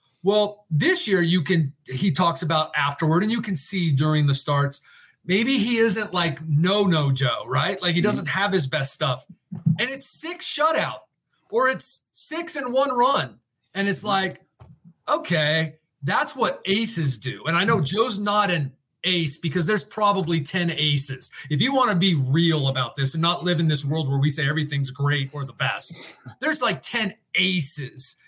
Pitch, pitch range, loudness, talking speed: 170 Hz, 145-200 Hz, -21 LUFS, 185 wpm